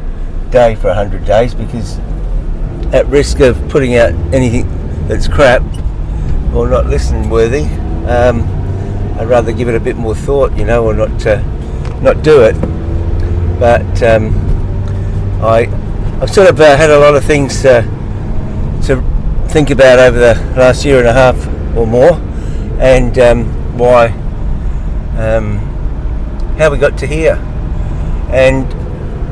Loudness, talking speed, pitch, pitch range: -11 LUFS, 145 wpm, 110 Hz, 85-120 Hz